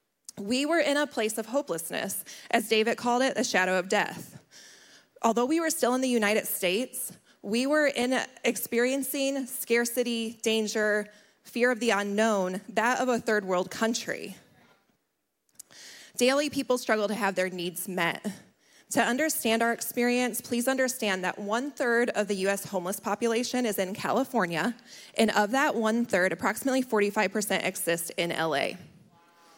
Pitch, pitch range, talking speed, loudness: 225 Hz, 200-245 Hz, 150 wpm, -27 LUFS